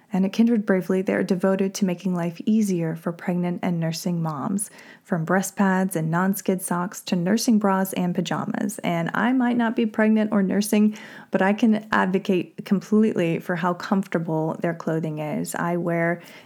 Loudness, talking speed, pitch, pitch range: -23 LUFS, 180 wpm, 190 Hz, 175-215 Hz